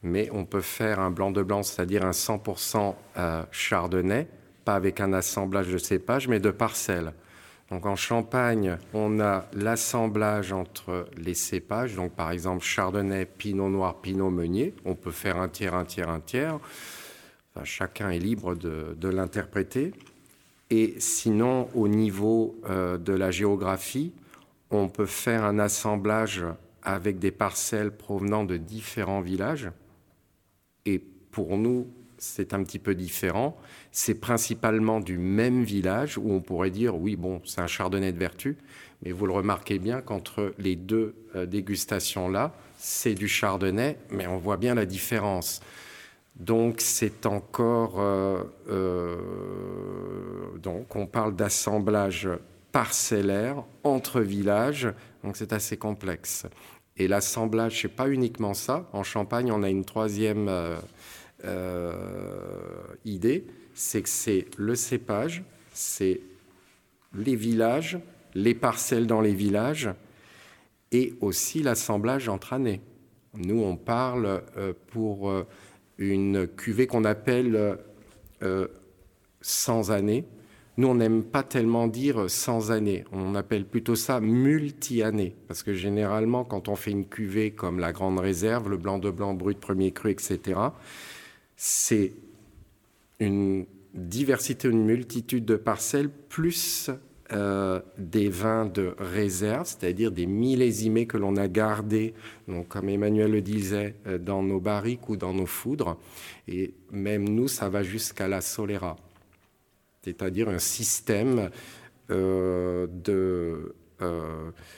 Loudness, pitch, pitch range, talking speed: -28 LUFS, 100 Hz, 95-115 Hz, 135 wpm